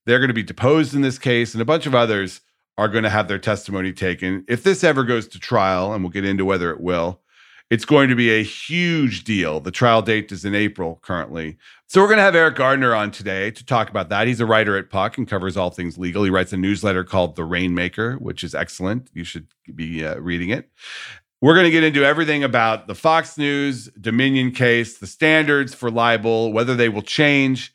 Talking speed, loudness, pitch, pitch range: 230 wpm, -19 LUFS, 110 Hz, 95-130 Hz